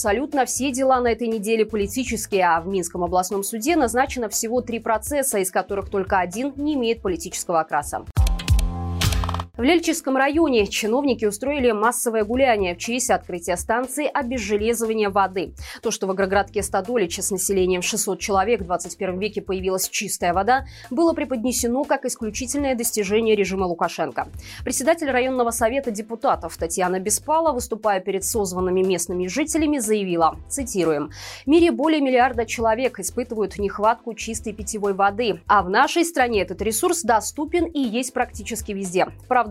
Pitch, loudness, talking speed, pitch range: 220 Hz, -22 LUFS, 145 wpm, 190-255 Hz